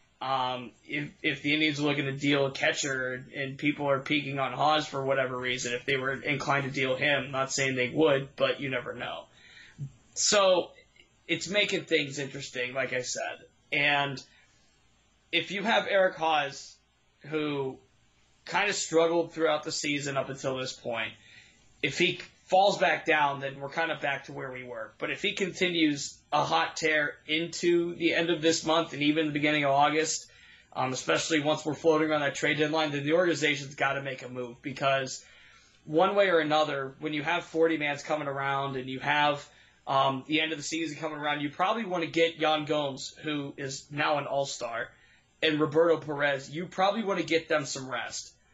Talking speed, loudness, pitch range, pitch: 190 wpm, -28 LUFS, 135-160 Hz, 145 Hz